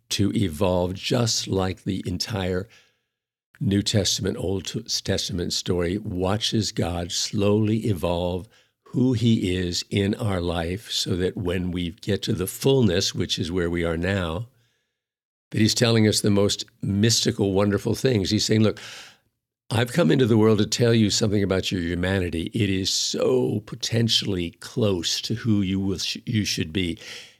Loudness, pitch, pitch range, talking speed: -23 LUFS, 100 Hz, 95-110 Hz, 155 wpm